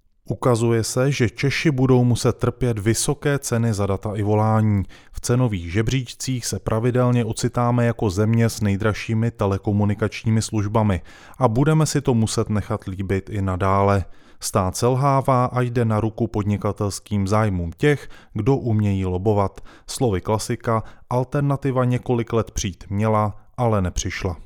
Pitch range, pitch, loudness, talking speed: 100-125 Hz, 110 Hz, -21 LUFS, 135 wpm